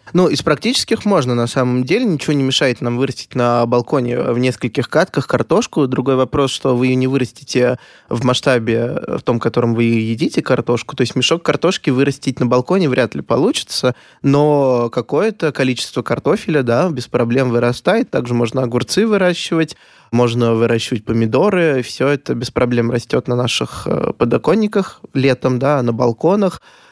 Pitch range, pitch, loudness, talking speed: 120-150 Hz, 130 Hz, -16 LUFS, 160 wpm